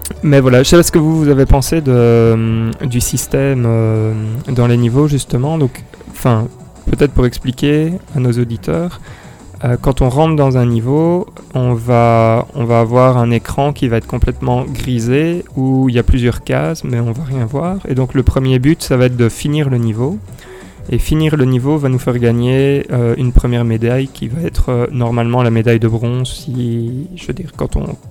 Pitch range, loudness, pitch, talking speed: 120-140 Hz, -14 LUFS, 125 Hz, 205 wpm